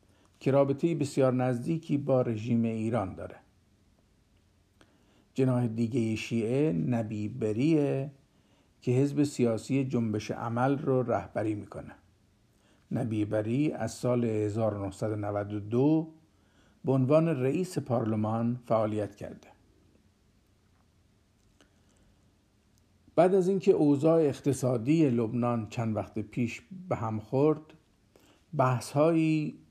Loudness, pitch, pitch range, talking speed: -29 LUFS, 115 Hz, 105-135 Hz, 95 wpm